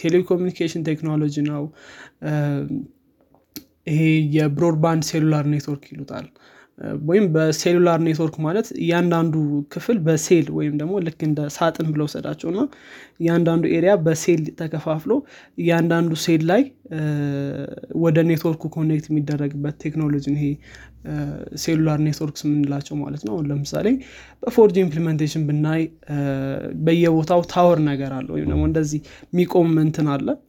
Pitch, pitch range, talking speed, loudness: 155 Hz, 150-170 Hz, 105 wpm, -21 LUFS